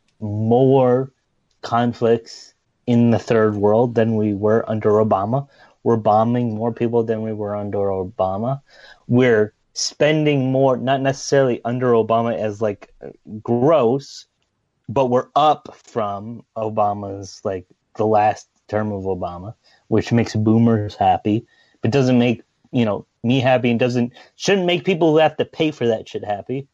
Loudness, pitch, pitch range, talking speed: -19 LUFS, 115 Hz, 110-130 Hz, 145 wpm